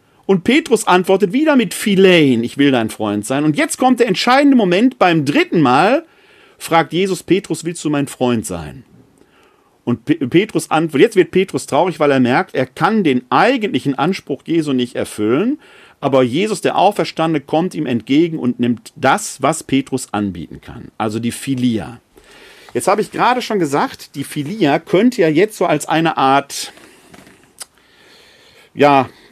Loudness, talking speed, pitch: -15 LUFS, 160 wpm, 160 Hz